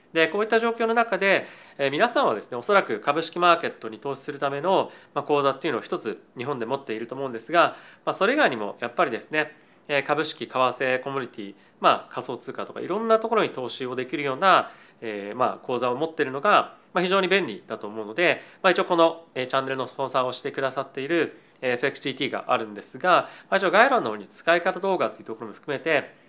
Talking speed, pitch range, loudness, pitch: 440 characters per minute, 130-175 Hz, -24 LUFS, 140 Hz